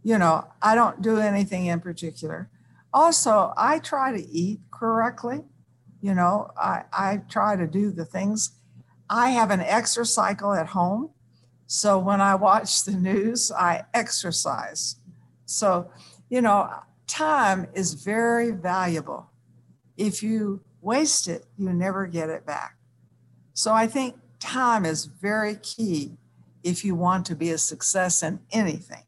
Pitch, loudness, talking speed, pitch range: 195 Hz, -24 LUFS, 145 wpm, 170-220 Hz